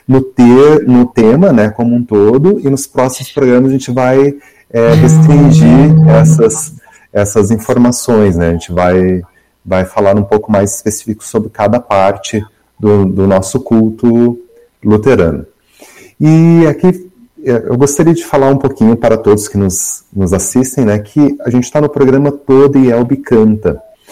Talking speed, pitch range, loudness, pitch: 155 wpm, 105-145 Hz, -9 LUFS, 125 Hz